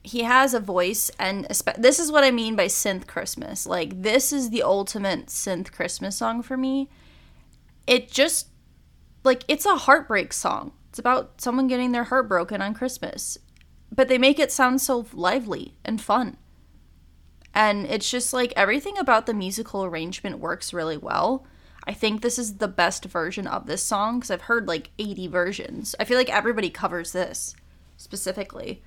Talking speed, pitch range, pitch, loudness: 175 wpm, 185-255 Hz, 220 Hz, -23 LUFS